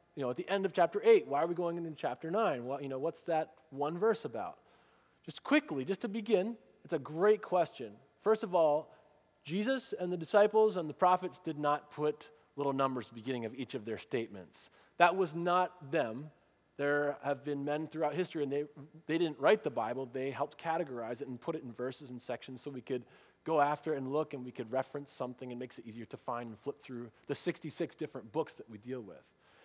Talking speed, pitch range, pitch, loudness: 225 wpm, 130-170 Hz, 150 Hz, -35 LUFS